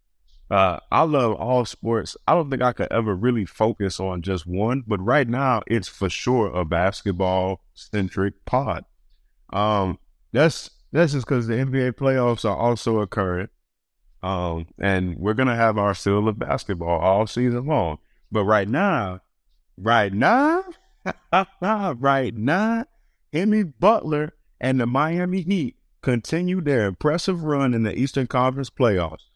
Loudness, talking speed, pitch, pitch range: -22 LUFS, 145 wpm, 115 Hz, 95-140 Hz